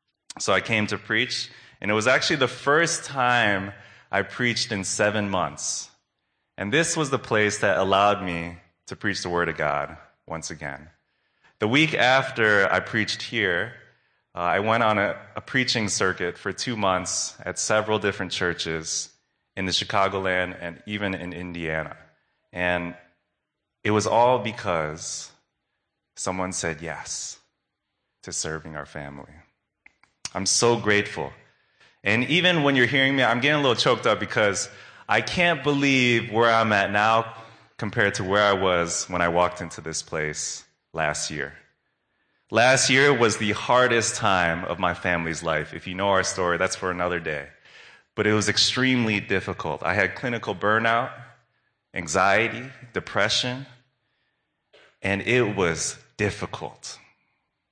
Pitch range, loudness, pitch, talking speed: 90-120 Hz, -23 LUFS, 100 Hz, 150 wpm